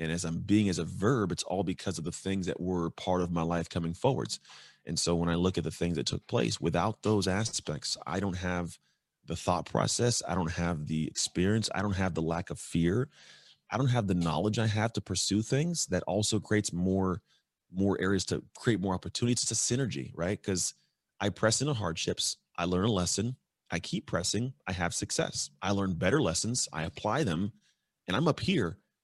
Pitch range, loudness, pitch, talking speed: 85-105 Hz, -31 LUFS, 95 Hz, 215 wpm